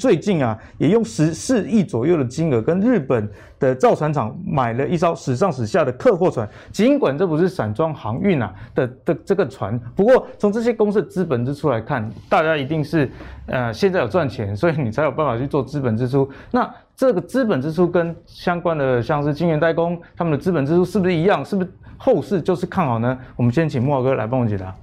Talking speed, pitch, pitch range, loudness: 325 characters per minute, 155 Hz, 130-185 Hz, -20 LUFS